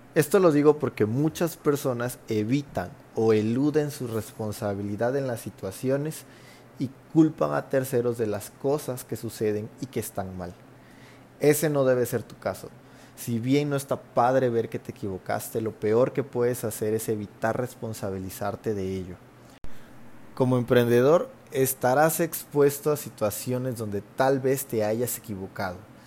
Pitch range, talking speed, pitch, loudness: 110-135 Hz, 145 wpm, 120 Hz, -26 LUFS